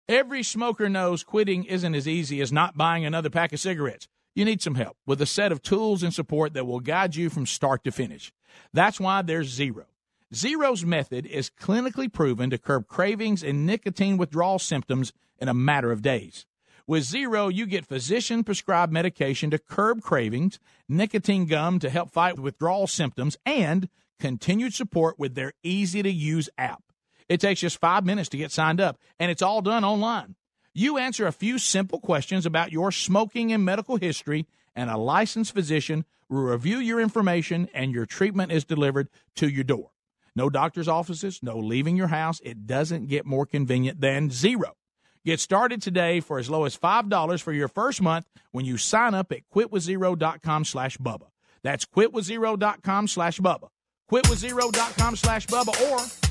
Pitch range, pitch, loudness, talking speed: 145-205 Hz, 175 Hz, -25 LUFS, 180 wpm